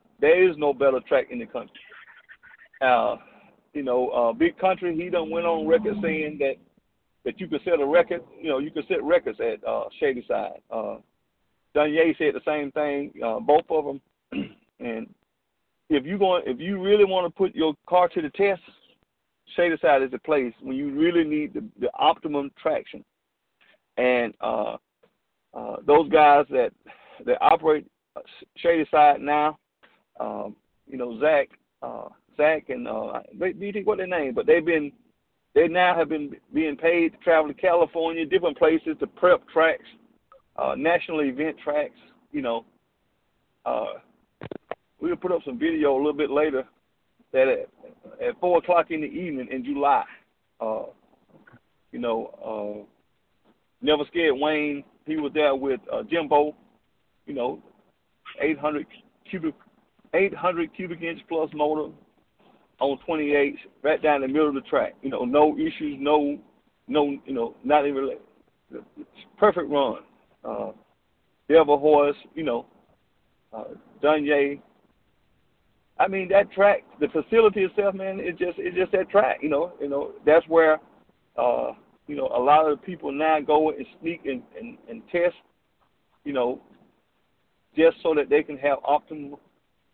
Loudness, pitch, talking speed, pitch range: -24 LUFS, 160 Hz, 160 wpm, 145-195 Hz